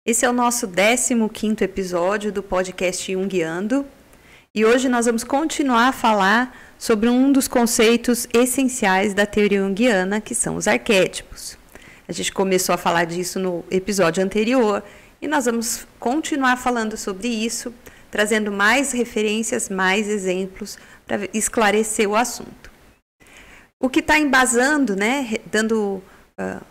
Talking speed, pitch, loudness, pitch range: 135 wpm, 220 Hz, -19 LUFS, 200-245 Hz